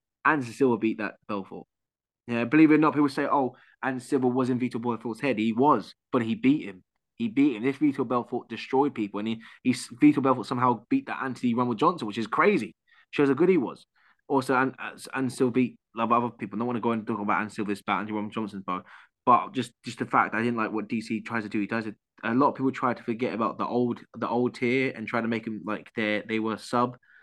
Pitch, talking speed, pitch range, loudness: 120 Hz, 255 wpm, 110-130 Hz, -27 LUFS